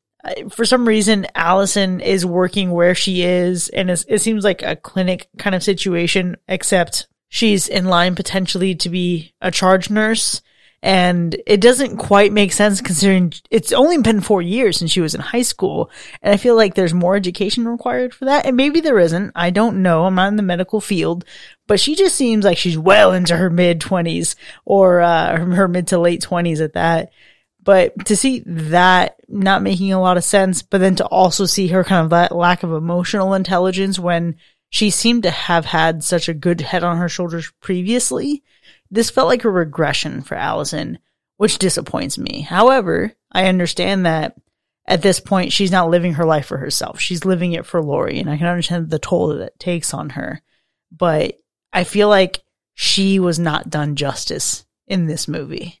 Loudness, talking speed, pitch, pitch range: -16 LUFS, 190 wpm, 185 Hz, 175-205 Hz